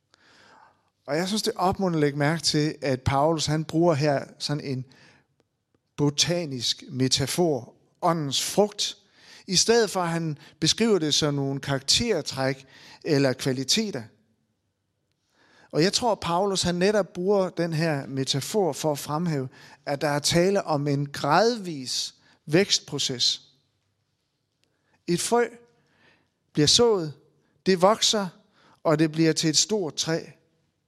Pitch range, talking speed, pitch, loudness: 135-180 Hz, 130 wpm, 150 Hz, -24 LUFS